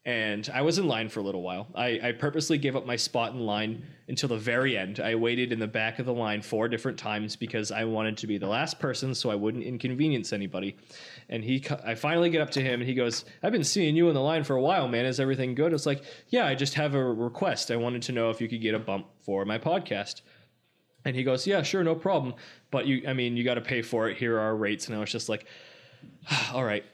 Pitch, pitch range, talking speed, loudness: 120 Hz, 110-140 Hz, 265 wpm, -29 LUFS